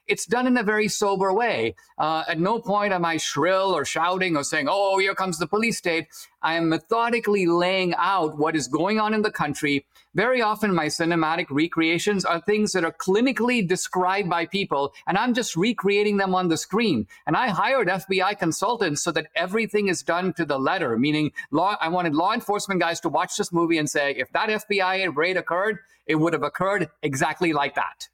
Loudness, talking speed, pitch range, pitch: -23 LUFS, 205 wpm, 160-205 Hz, 185 Hz